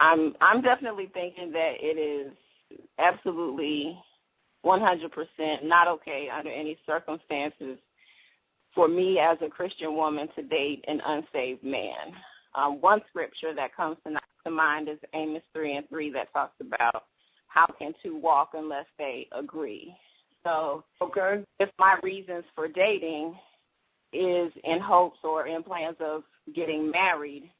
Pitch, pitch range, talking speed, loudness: 160 Hz, 150-175 Hz, 140 wpm, -27 LUFS